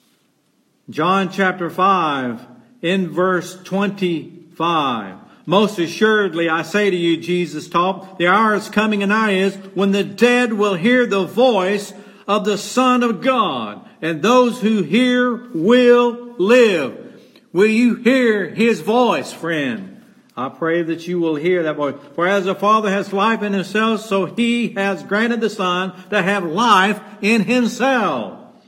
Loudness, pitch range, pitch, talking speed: -17 LUFS, 180-230 Hz, 200 Hz, 150 wpm